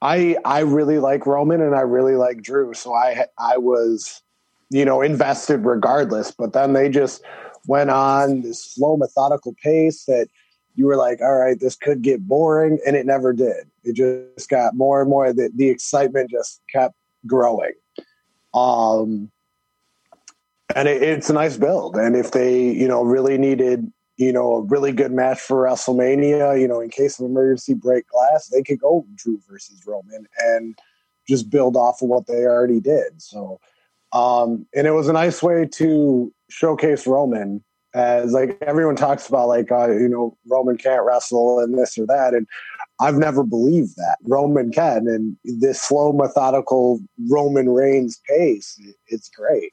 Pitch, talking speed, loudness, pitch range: 130 Hz, 170 wpm, -18 LUFS, 125-140 Hz